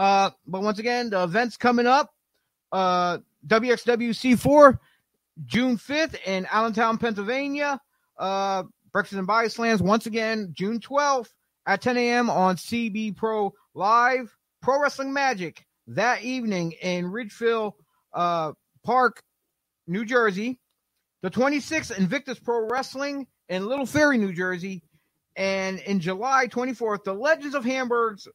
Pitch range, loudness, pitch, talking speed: 190-255 Hz, -24 LUFS, 225 Hz, 125 wpm